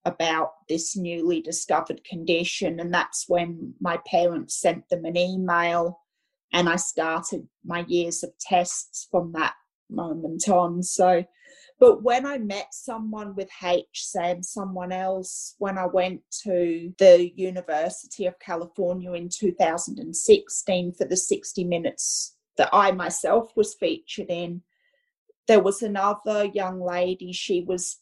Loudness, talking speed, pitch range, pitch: -24 LUFS, 135 wpm, 175-200 Hz, 180 Hz